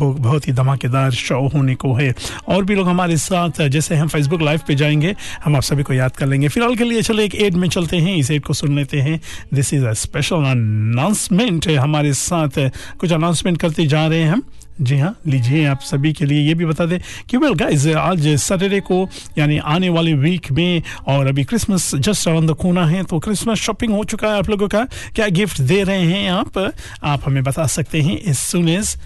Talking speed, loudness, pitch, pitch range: 220 wpm, -17 LUFS, 160 Hz, 140-185 Hz